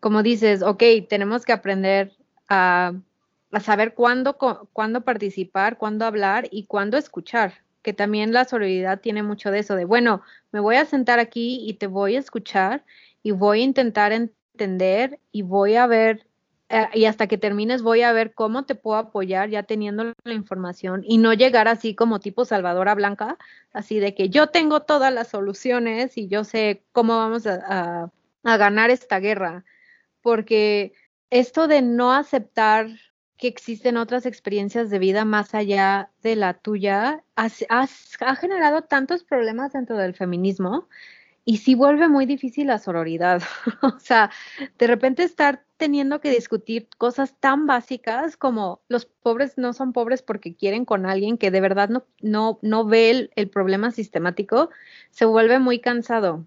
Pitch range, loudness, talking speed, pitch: 205-250 Hz, -21 LUFS, 165 wpm, 225 Hz